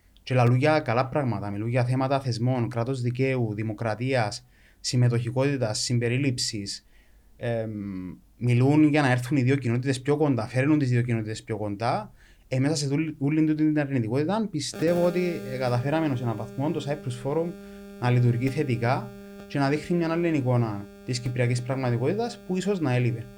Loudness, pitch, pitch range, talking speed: -26 LUFS, 130 Hz, 115-150 Hz, 165 wpm